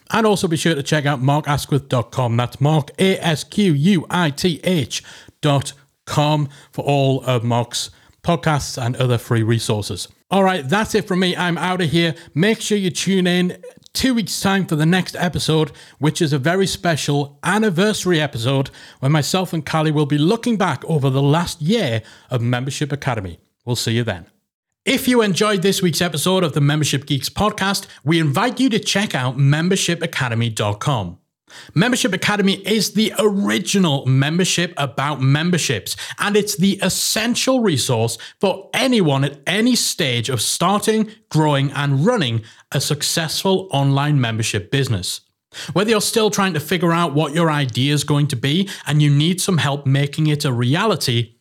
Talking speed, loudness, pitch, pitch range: 160 wpm, -18 LUFS, 155 Hz, 140-190 Hz